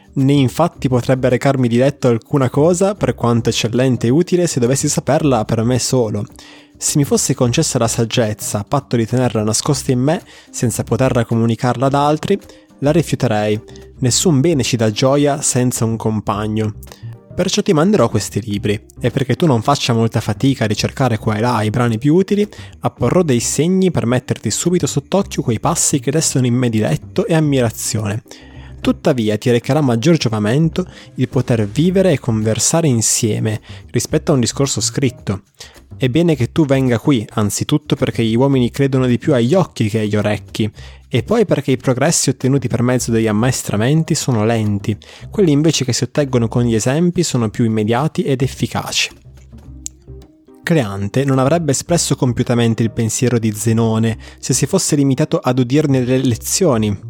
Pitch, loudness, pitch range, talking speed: 125 Hz, -16 LUFS, 115-145 Hz, 170 wpm